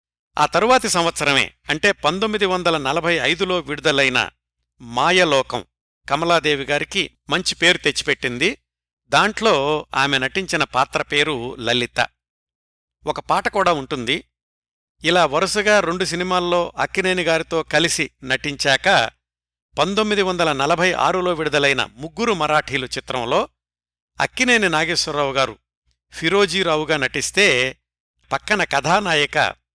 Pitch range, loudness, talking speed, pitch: 120-175 Hz, -18 LUFS, 95 wpm, 150 Hz